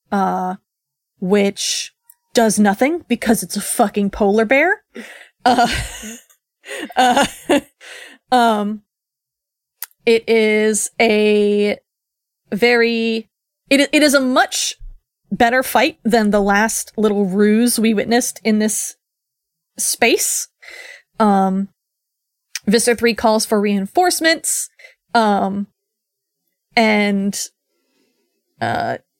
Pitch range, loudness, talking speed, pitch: 205-255 Hz, -16 LUFS, 90 wpm, 225 Hz